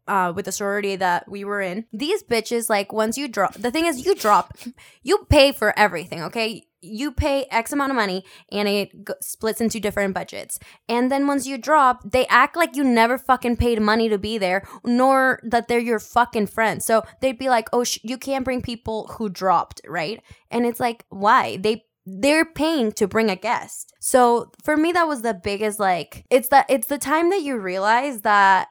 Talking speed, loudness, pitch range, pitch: 210 wpm, -21 LUFS, 210-265 Hz, 230 Hz